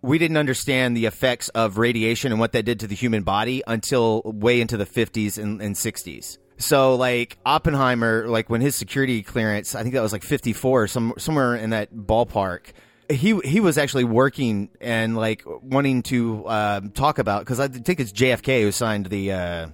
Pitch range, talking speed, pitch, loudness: 110-130 Hz, 190 wpm, 115 Hz, -22 LUFS